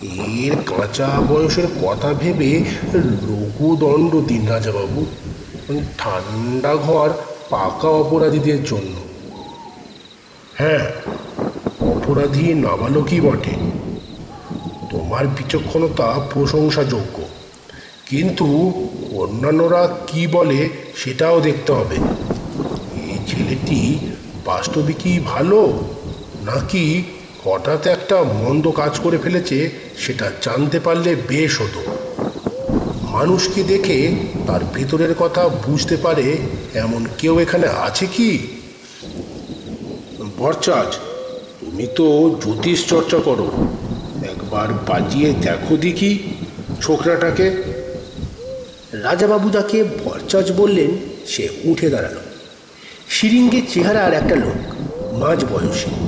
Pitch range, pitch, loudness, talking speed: 135-175 Hz, 155 Hz, -18 LUFS, 85 wpm